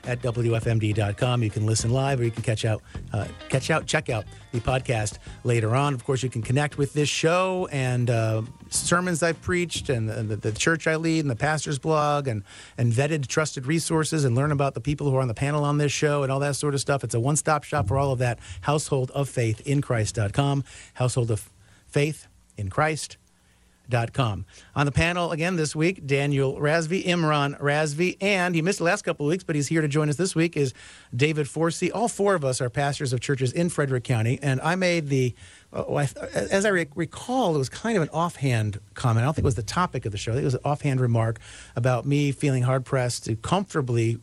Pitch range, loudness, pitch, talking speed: 120-155 Hz, -25 LUFS, 140 Hz, 225 wpm